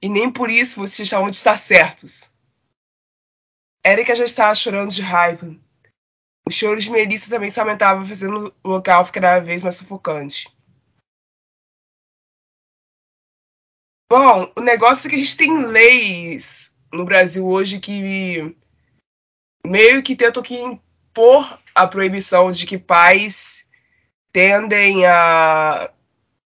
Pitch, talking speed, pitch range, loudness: 195 Hz, 120 wpm, 180-225 Hz, -14 LUFS